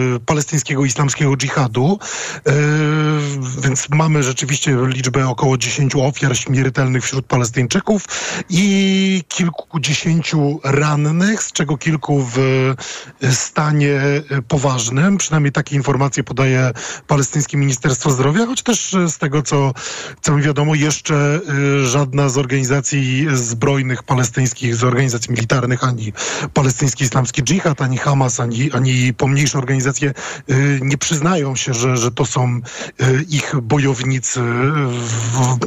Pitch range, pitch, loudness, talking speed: 130-150 Hz, 140 Hz, -16 LUFS, 115 wpm